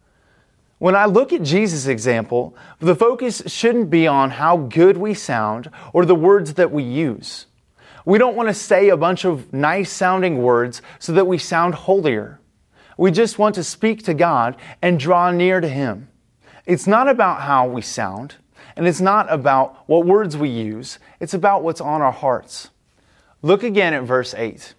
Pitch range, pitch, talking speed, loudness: 135-195 Hz, 175 Hz, 180 wpm, -17 LUFS